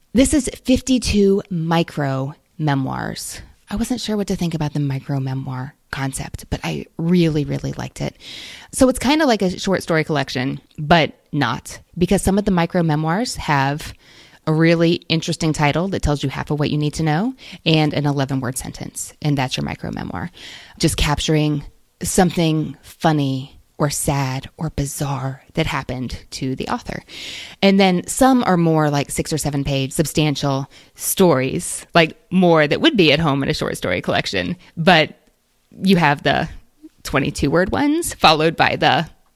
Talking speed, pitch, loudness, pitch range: 170 wpm, 155 Hz, -19 LUFS, 140-180 Hz